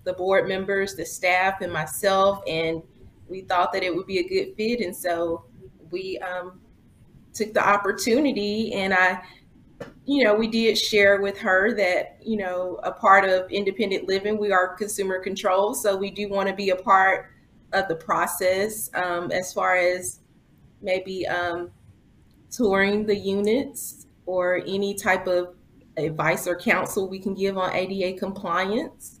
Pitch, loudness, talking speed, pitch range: 195 Hz, -23 LUFS, 160 wpm, 180-205 Hz